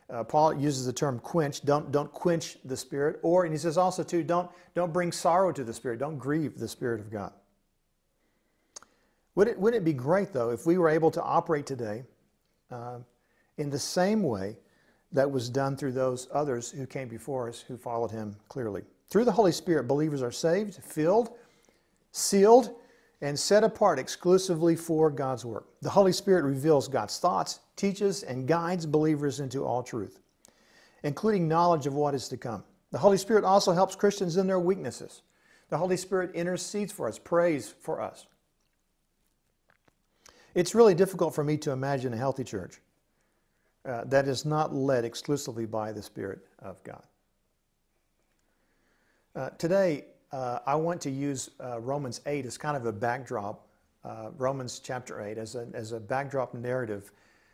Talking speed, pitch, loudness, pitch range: 170 wpm, 145 Hz, -28 LUFS, 125-175 Hz